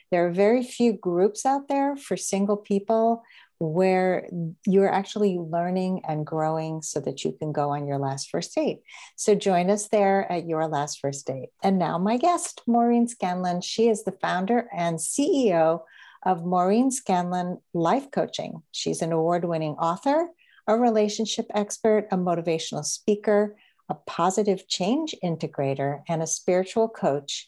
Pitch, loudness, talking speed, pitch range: 185 Hz, -25 LUFS, 155 wpm, 165-215 Hz